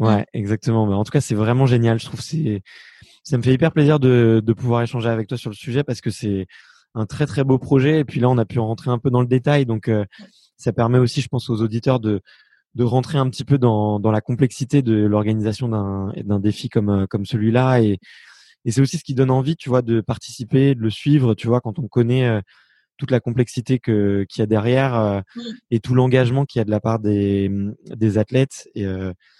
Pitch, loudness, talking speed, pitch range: 120 Hz, -19 LUFS, 240 wpm, 110-130 Hz